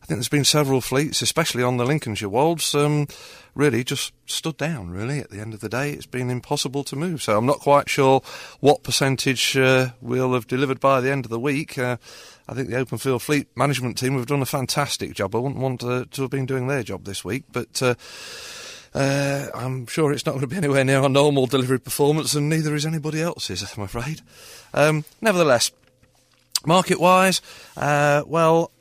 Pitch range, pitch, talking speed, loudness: 125-145 Hz, 135 Hz, 205 wpm, -21 LUFS